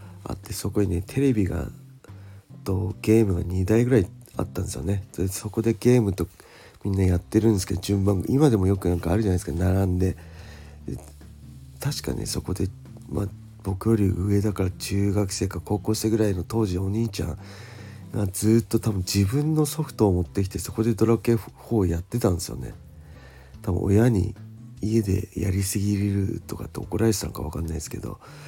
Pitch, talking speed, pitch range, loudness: 100 Hz, 360 characters per minute, 90-110 Hz, -25 LUFS